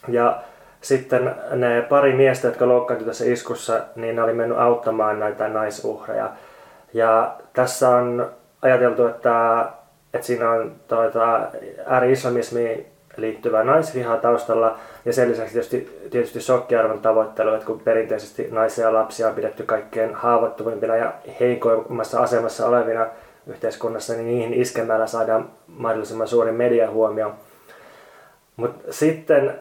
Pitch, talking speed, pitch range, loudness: 115 Hz, 120 wpm, 110-120 Hz, -21 LUFS